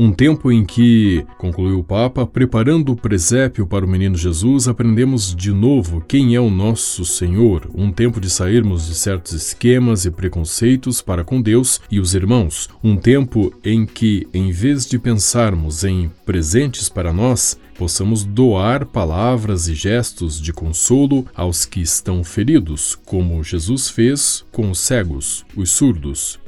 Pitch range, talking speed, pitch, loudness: 90-120 Hz, 155 wpm, 100 Hz, -16 LUFS